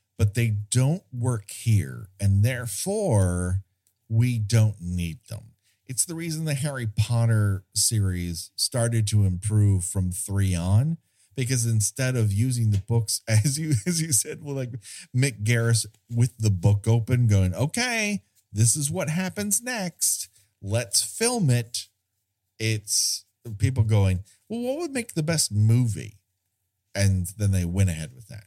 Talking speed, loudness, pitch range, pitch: 150 wpm, -24 LUFS, 100-130 Hz, 110 Hz